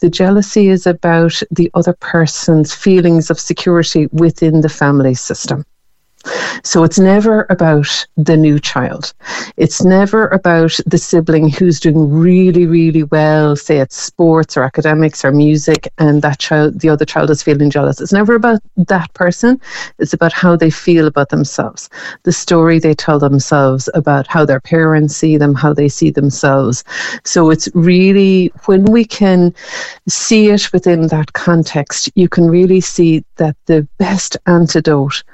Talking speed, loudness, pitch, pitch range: 155 wpm, -11 LUFS, 165 Hz, 155-180 Hz